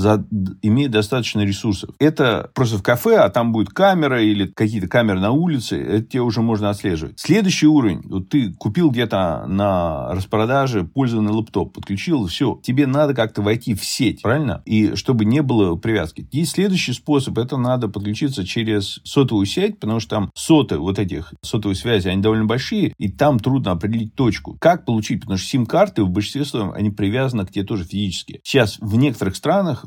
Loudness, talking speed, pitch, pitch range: -19 LUFS, 180 wpm, 110 Hz, 100-135 Hz